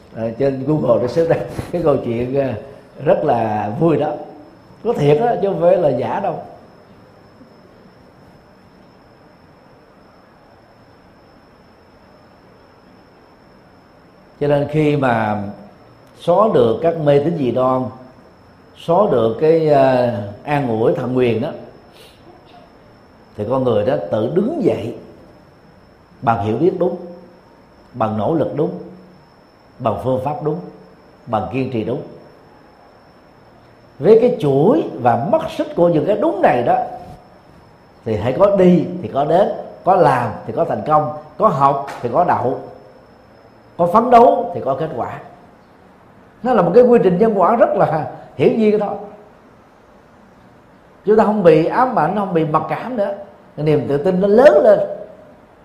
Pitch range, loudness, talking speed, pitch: 120-195 Hz, -16 LUFS, 145 wpm, 150 Hz